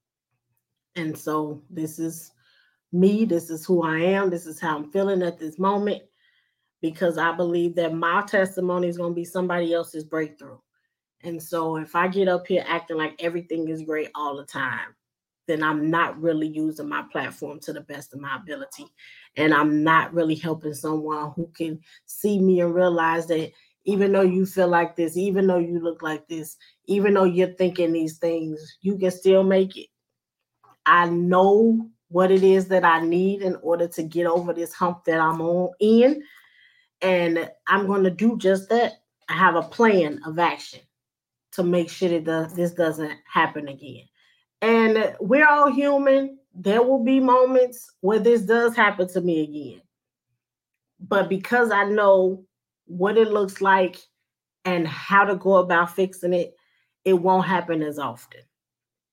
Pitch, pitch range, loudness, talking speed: 175 Hz, 160-190 Hz, -22 LUFS, 175 wpm